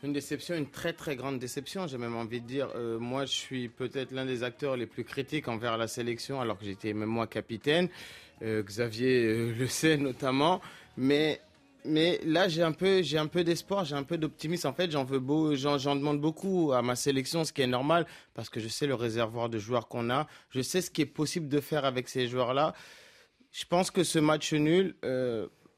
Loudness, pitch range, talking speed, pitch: -31 LUFS, 120-155 Hz, 225 wpm, 140 Hz